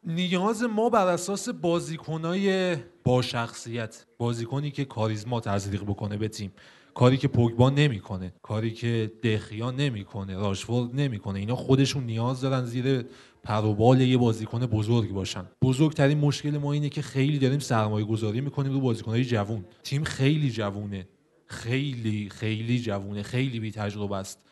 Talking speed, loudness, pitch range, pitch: 140 wpm, -27 LUFS, 110-140 Hz, 120 Hz